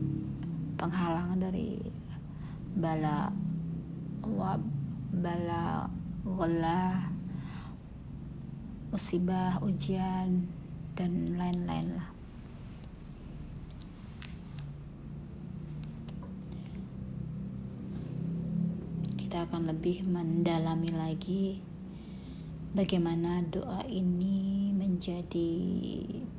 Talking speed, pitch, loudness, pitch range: 45 wpm, 175 Hz, -34 LUFS, 160-185 Hz